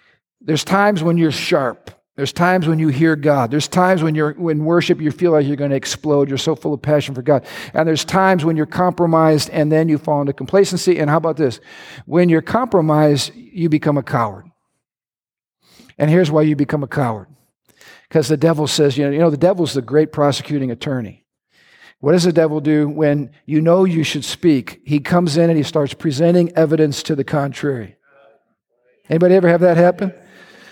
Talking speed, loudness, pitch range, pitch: 200 wpm, -16 LUFS, 145-170 Hz, 155 Hz